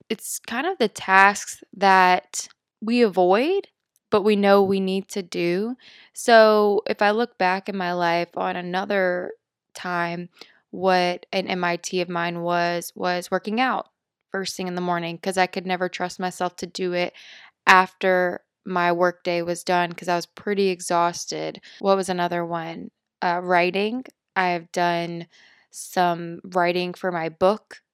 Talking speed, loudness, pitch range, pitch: 155 wpm, -22 LUFS, 175-195 Hz, 185 Hz